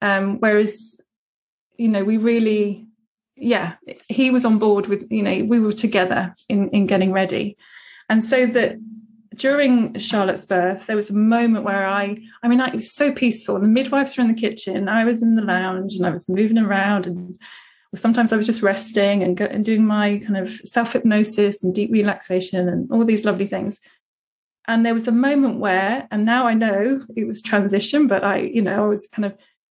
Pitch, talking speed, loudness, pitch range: 215 Hz, 205 wpm, -19 LUFS, 200-230 Hz